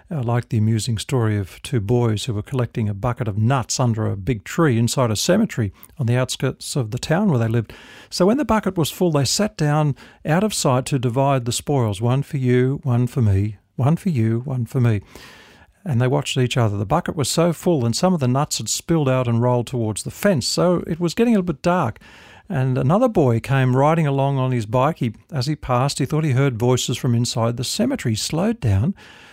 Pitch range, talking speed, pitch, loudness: 120-155 Hz, 235 wpm, 130 Hz, -20 LUFS